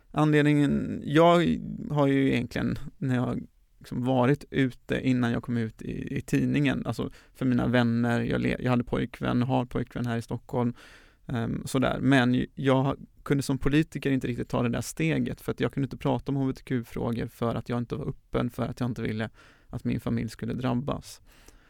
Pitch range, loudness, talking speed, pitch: 120-140 Hz, -28 LUFS, 190 wpm, 125 Hz